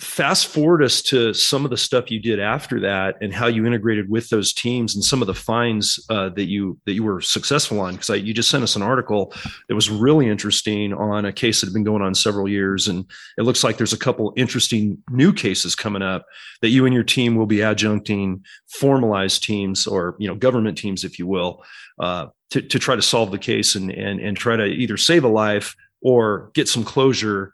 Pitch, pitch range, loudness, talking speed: 110 Hz, 100-120 Hz, -19 LUFS, 225 wpm